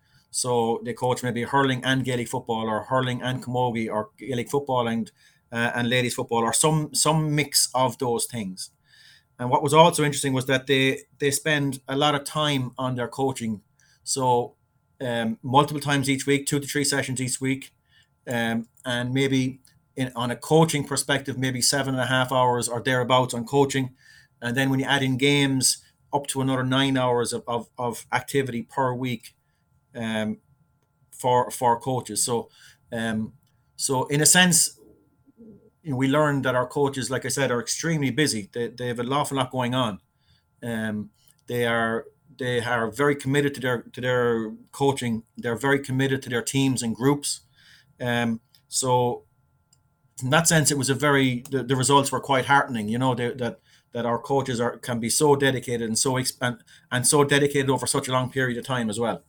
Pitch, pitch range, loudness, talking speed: 130 Hz, 120-140 Hz, -24 LUFS, 190 wpm